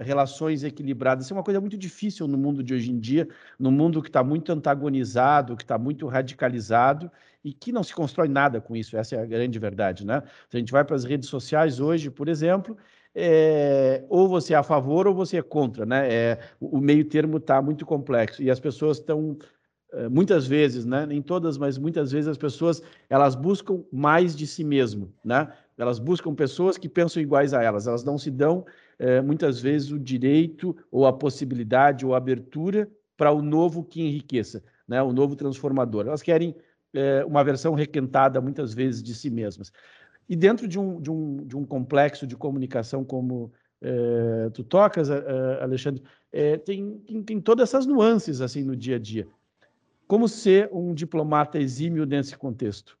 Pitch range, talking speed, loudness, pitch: 130-160 Hz, 185 wpm, -24 LUFS, 145 Hz